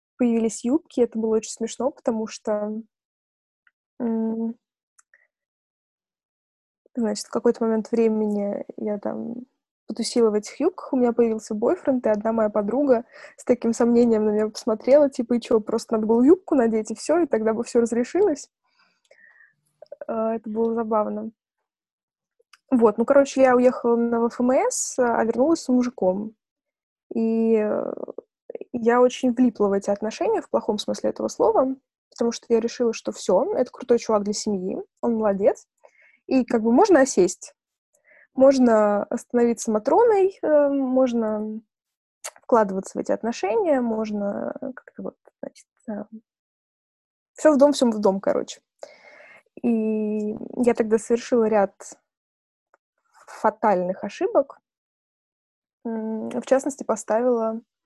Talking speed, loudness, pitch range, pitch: 125 wpm, -22 LUFS, 220-270 Hz, 235 Hz